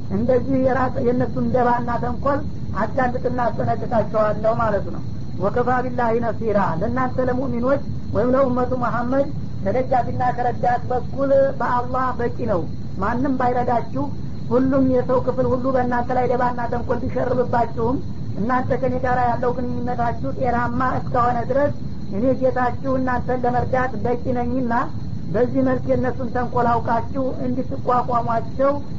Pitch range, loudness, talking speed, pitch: 240-255 Hz, -21 LUFS, 110 wpm, 250 Hz